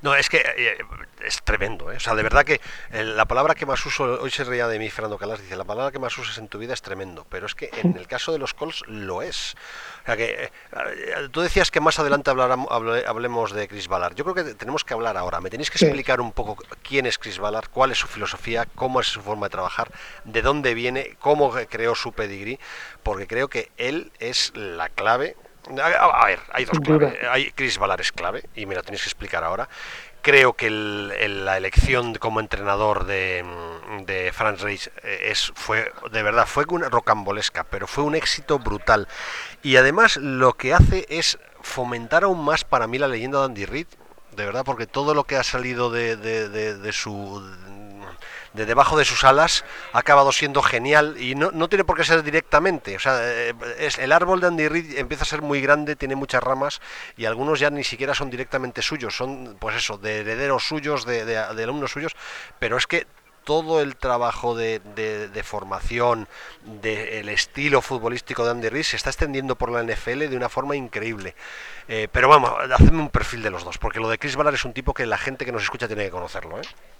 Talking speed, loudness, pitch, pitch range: 215 wpm, -22 LUFS, 125 Hz, 110-145 Hz